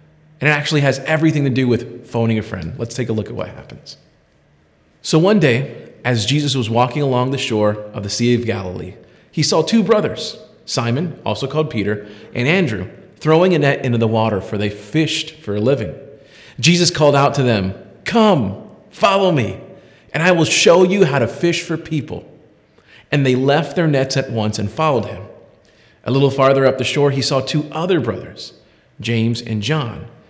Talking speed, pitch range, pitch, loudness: 190 wpm, 110-155 Hz, 135 Hz, -17 LUFS